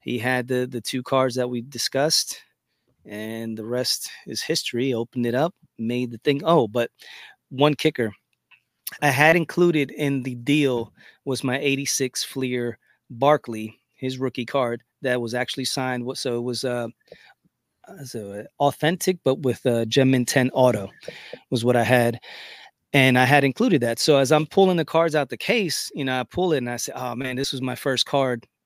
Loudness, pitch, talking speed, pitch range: -22 LUFS, 130 Hz, 180 wpm, 120-140 Hz